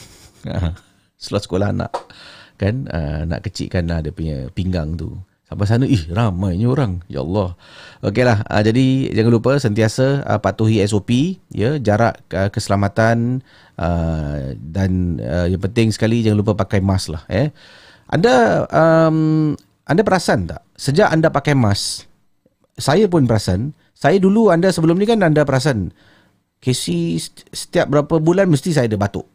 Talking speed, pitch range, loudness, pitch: 150 wpm, 95-135 Hz, -17 LUFS, 105 Hz